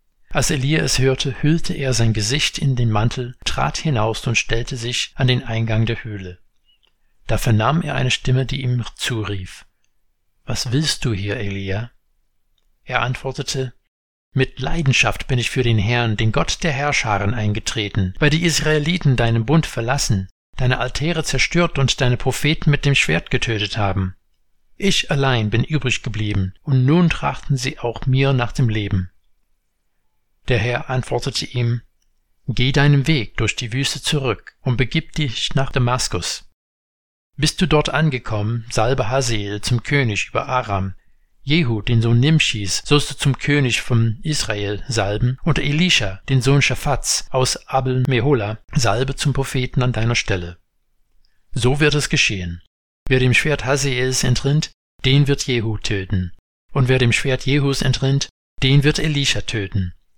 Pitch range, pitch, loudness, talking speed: 110-140 Hz, 125 Hz, -19 LUFS, 155 wpm